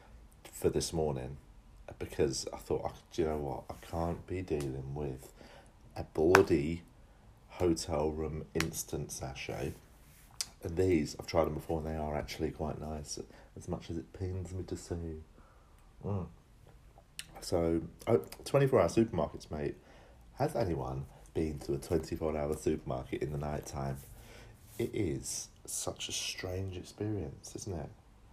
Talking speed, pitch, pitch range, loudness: 140 wpm, 80 Hz, 75-90 Hz, -35 LUFS